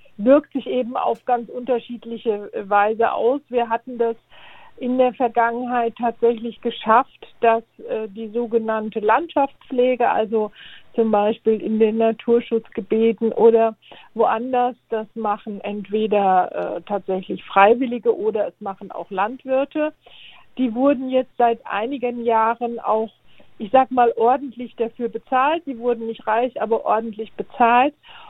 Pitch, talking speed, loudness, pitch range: 235 Hz, 125 wpm, -20 LUFS, 220-250 Hz